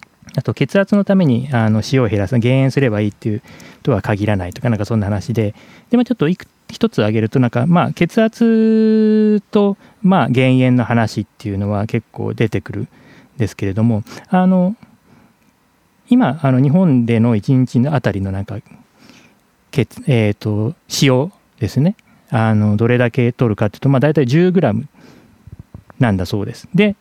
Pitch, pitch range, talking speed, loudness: 125 Hz, 110-180 Hz, 305 characters per minute, -16 LUFS